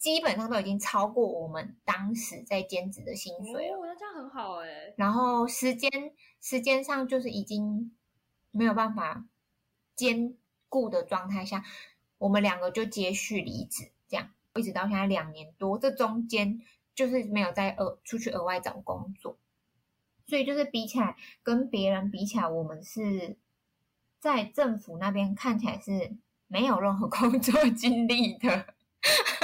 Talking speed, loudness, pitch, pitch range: 235 characters per minute, -30 LUFS, 220 Hz, 200-255 Hz